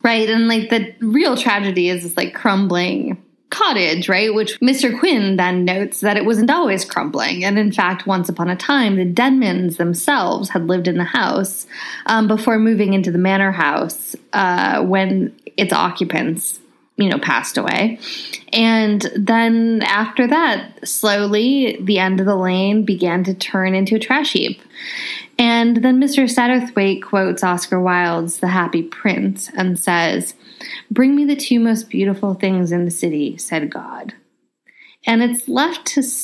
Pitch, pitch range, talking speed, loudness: 205 Hz, 185-235 Hz, 160 wpm, -16 LUFS